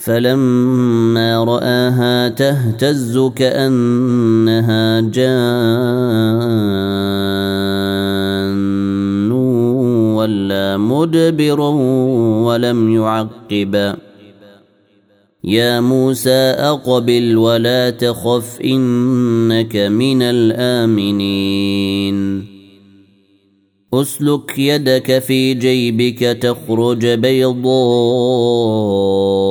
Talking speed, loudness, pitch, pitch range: 45 wpm, -14 LUFS, 115 Hz, 100-125 Hz